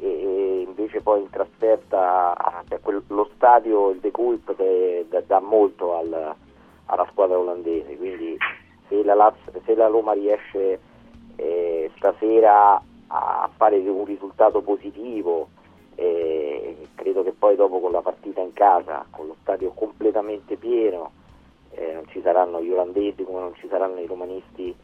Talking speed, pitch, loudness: 125 wpm, 350 Hz, -21 LUFS